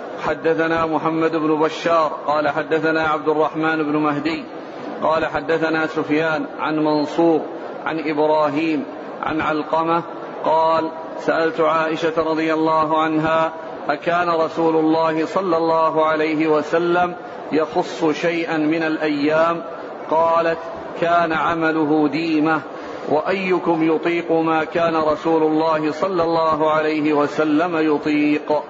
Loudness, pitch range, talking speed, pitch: -19 LUFS, 155-165 Hz, 105 wpm, 160 Hz